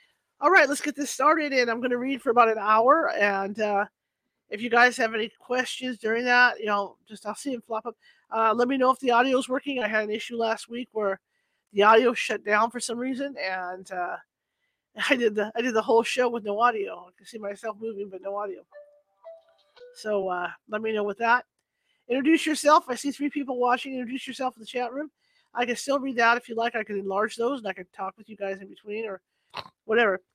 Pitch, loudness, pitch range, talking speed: 235 Hz, -25 LUFS, 210-260 Hz, 235 wpm